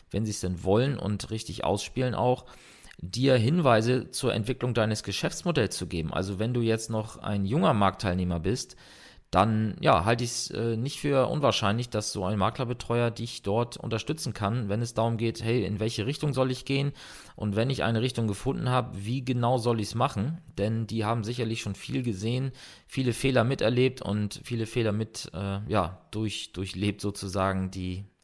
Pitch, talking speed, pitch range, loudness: 115 Hz, 185 wpm, 100-125 Hz, -28 LUFS